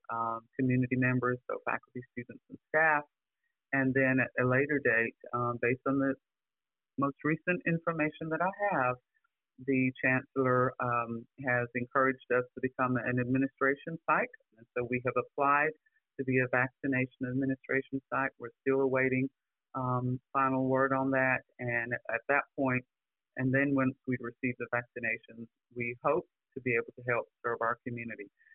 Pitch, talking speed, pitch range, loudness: 130 Hz, 160 wpm, 125-135 Hz, -31 LUFS